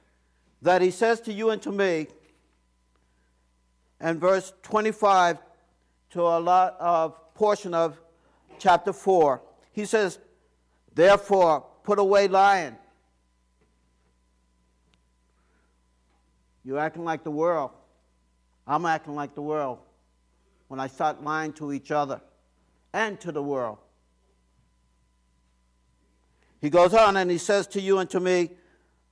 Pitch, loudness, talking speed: 145 Hz, -24 LUFS, 115 wpm